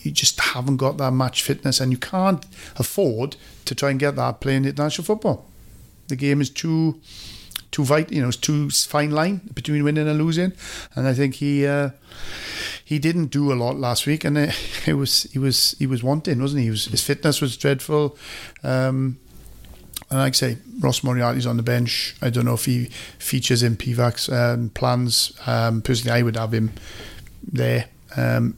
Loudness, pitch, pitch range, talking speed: -21 LUFS, 135 Hz, 120-145 Hz, 195 wpm